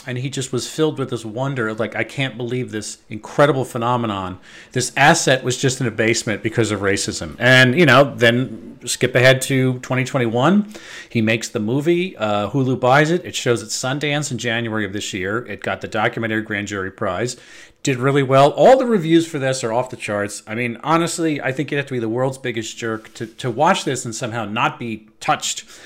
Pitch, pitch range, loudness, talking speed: 125 Hz, 110-135 Hz, -18 LUFS, 215 wpm